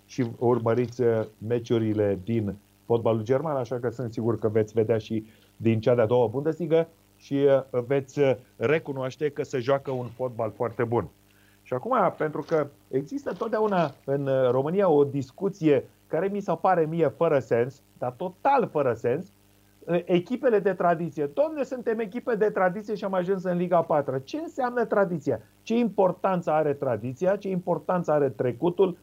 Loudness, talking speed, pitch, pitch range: -26 LUFS, 155 wpm, 140 Hz, 120-180 Hz